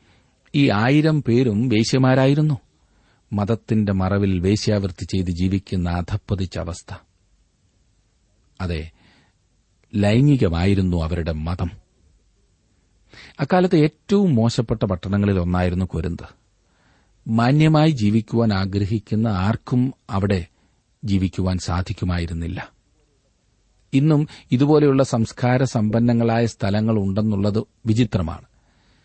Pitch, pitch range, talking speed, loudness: 105 Hz, 90-120 Hz, 70 wpm, -20 LUFS